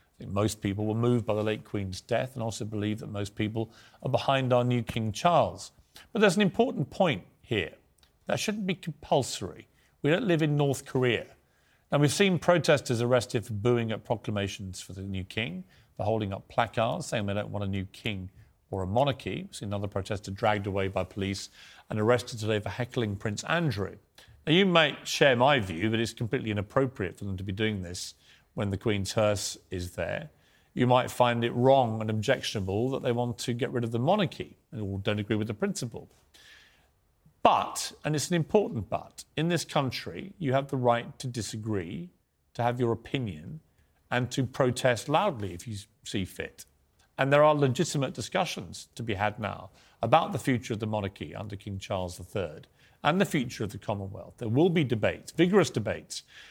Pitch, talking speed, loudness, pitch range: 115 Hz, 195 wpm, -29 LUFS, 100-130 Hz